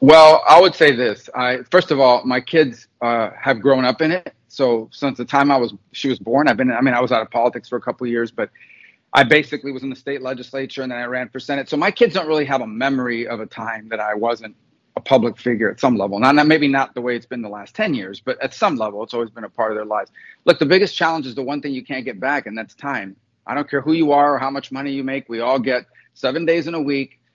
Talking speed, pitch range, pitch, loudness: 290 wpm, 120-145 Hz, 130 Hz, -18 LUFS